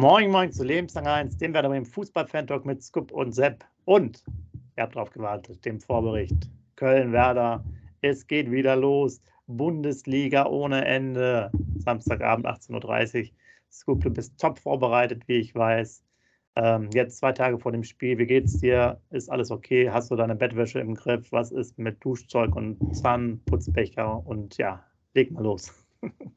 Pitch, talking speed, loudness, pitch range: 120 Hz, 160 wpm, -26 LUFS, 110-135 Hz